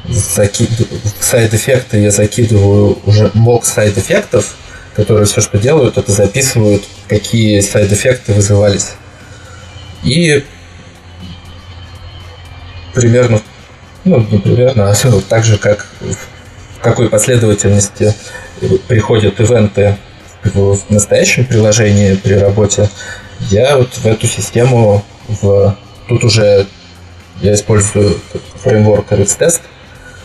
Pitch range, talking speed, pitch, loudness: 100-110 Hz, 100 wpm, 105 Hz, -10 LUFS